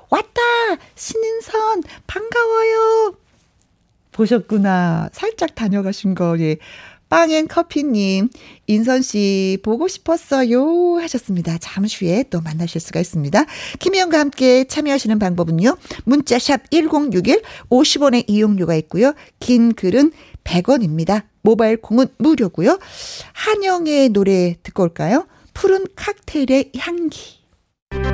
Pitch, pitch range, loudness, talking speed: 255 Hz, 195-330 Hz, -17 LUFS, 245 characters per minute